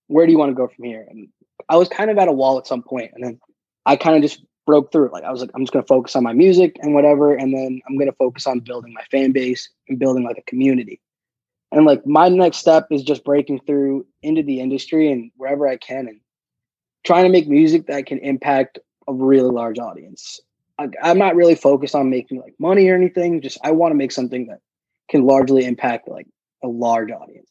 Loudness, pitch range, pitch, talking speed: -16 LUFS, 130-160 Hz, 135 Hz, 240 wpm